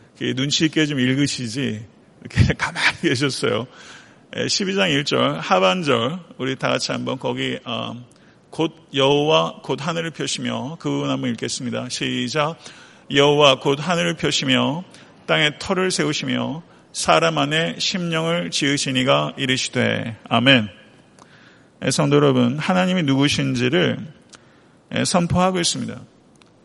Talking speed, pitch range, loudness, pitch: 260 characters per minute, 130-165 Hz, -20 LUFS, 140 Hz